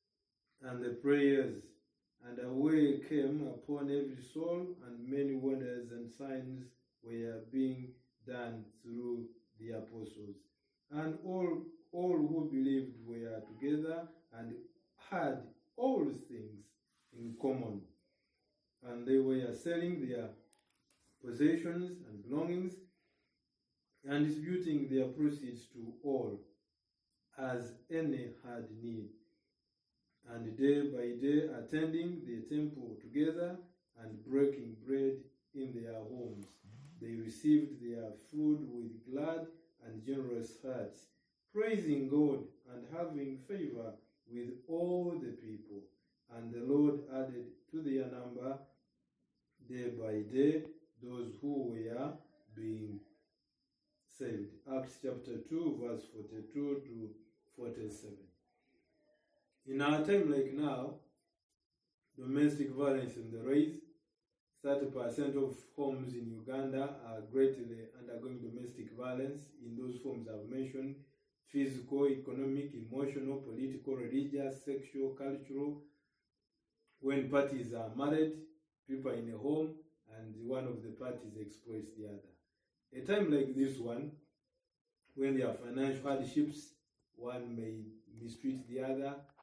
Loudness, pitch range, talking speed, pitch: -38 LUFS, 115-145 Hz, 115 wpm, 135 Hz